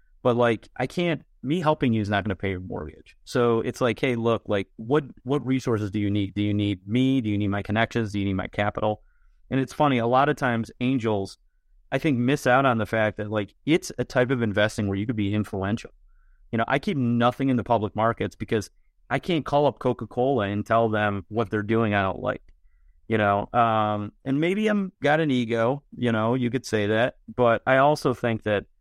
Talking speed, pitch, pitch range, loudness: 230 wpm, 115 Hz, 105-130 Hz, -24 LUFS